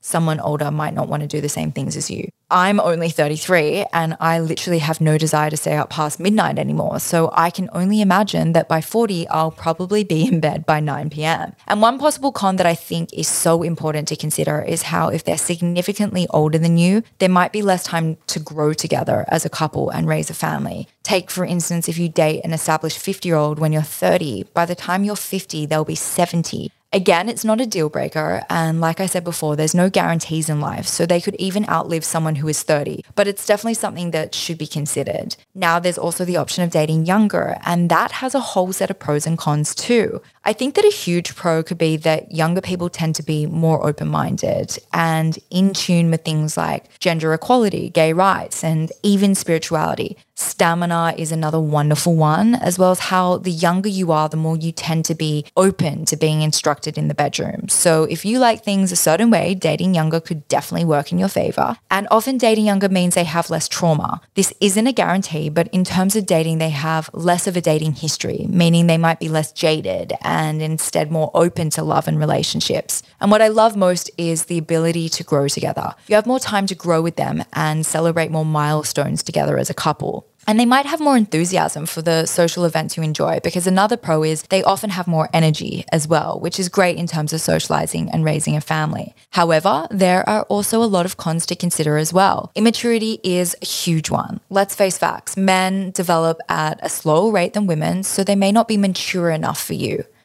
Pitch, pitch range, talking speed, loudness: 170 Hz, 155-190 Hz, 215 wpm, -18 LUFS